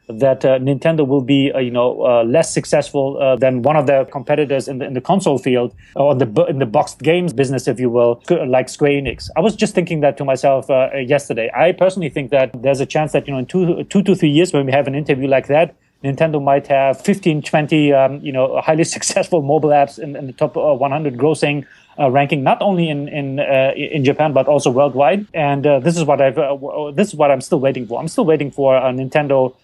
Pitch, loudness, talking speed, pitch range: 140 Hz, -16 LUFS, 245 wpm, 135-155 Hz